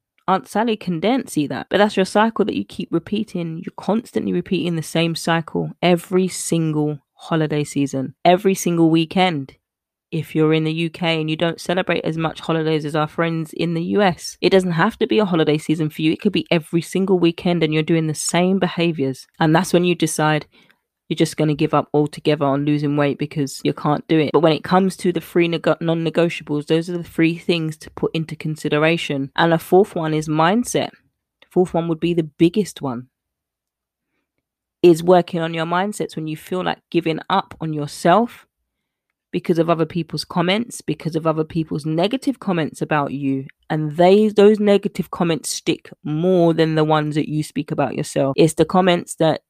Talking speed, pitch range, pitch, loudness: 200 wpm, 155-180 Hz, 165 Hz, -19 LUFS